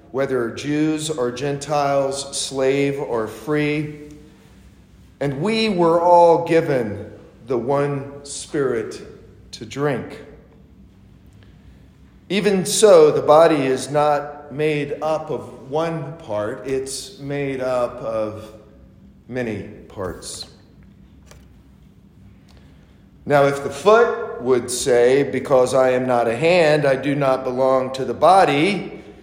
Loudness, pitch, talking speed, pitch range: -19 LUFS, 140 Hz, 110 wpm, 125-150 Hz